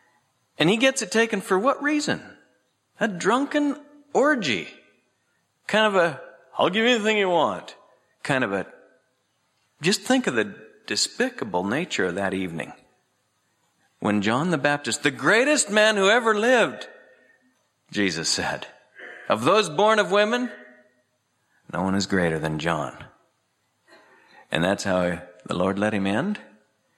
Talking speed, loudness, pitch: 140 wpm, -23 LUFS, 175 Hz